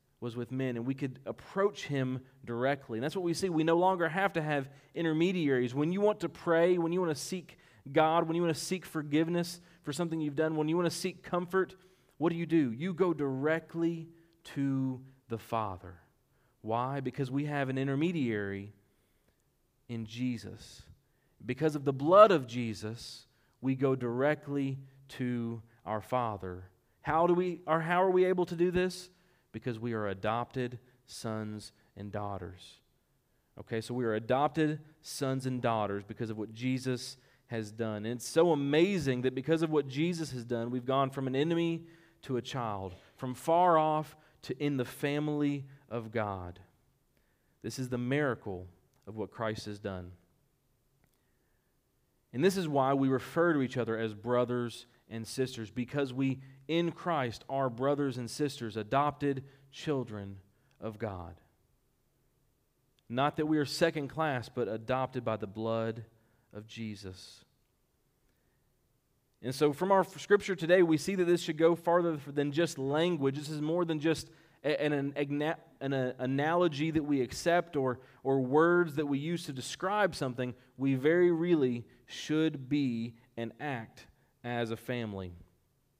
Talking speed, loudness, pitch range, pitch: 160 wpm, -32 LUFS, 120-160 Hz, 135 Hz